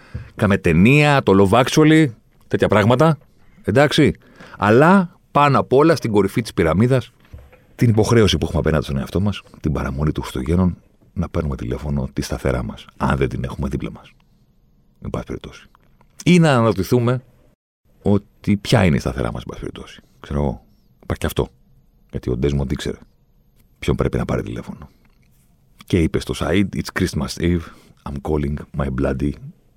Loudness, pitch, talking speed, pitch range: -18 LUFS, 85 Hz, 160 wpm, 70-115 Hz